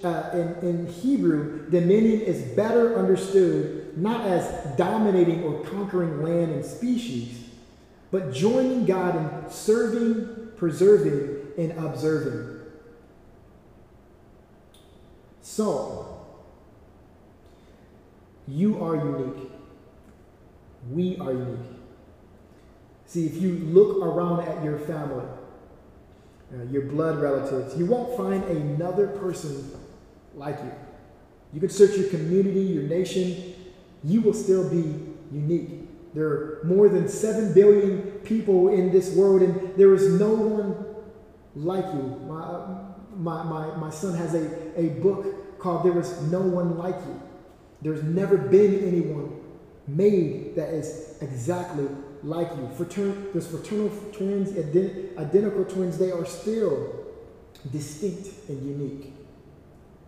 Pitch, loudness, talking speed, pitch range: 175 Hz, -24 LUFS, 120 wpm, 150-195 Hz